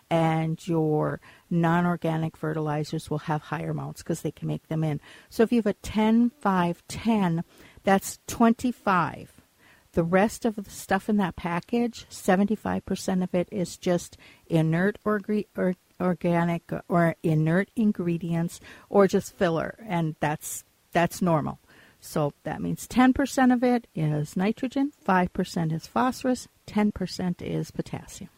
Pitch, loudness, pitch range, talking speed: 175 Hz, -26 LUFS, 160-210 Hz, 135 wpm